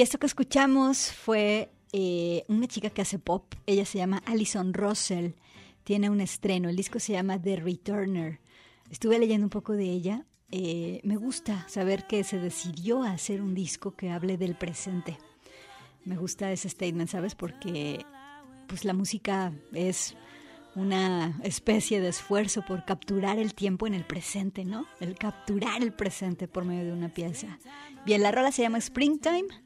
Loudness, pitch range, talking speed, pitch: -30 LUFS, 180-215 Hz, 165 wpm, 195 Hz